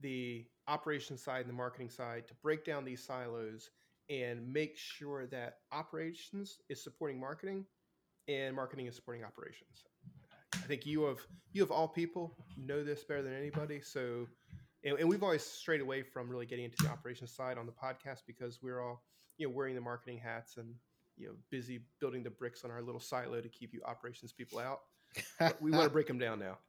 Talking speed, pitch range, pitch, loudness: 200 wpm, 120-150 Hz, 130 Hz, -41 LUFS